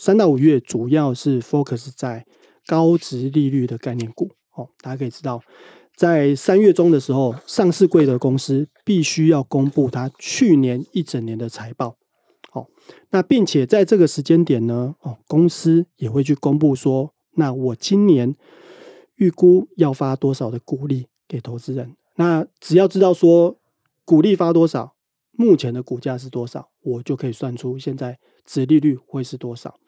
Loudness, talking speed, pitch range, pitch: -18 LUFS, 255 characters per minute, 130-170 Hz, 140 Hz